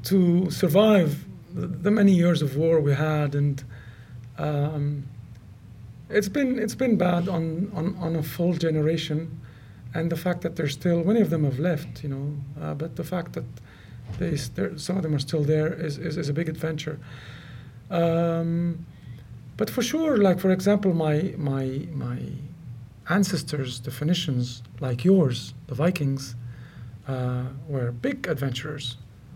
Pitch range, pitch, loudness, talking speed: 130-170 Hz, 150 Hz, -25 LUFS, 150 wpm